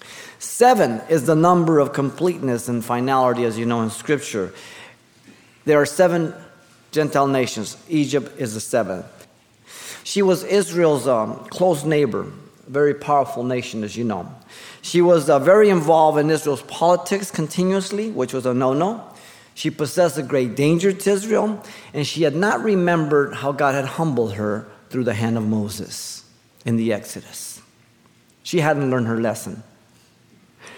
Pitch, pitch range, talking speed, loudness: 145 Hz, 125-175 Hz, 150 wpm, -20 LUFS